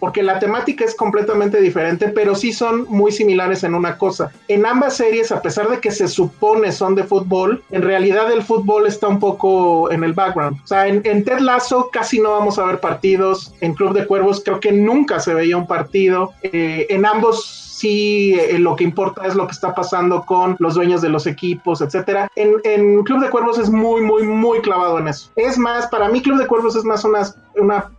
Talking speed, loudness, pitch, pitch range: 220 wpm, -16 LUFS, 200 Hz, 185-220 Hz